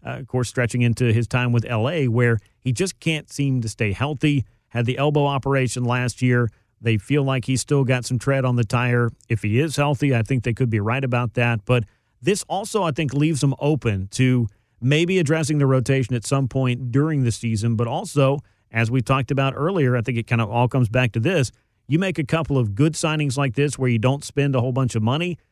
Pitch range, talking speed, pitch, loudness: 120-140 Hz, 235 wpm, 130 Hz, -21 LUFS